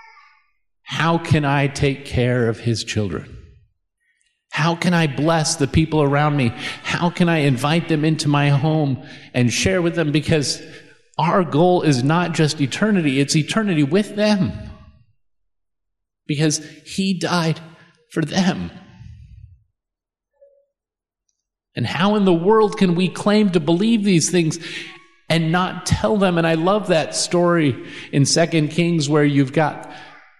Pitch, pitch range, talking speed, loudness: 160 Hz, 140-180 Hz, 140 wpm, -18 LUFS